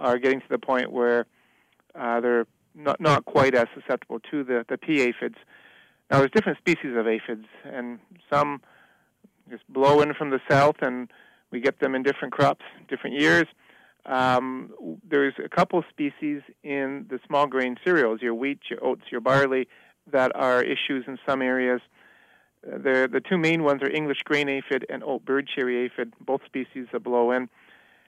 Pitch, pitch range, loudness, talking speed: 135 Hz, 125-145 Hz, -24 LUFS, 175 wpm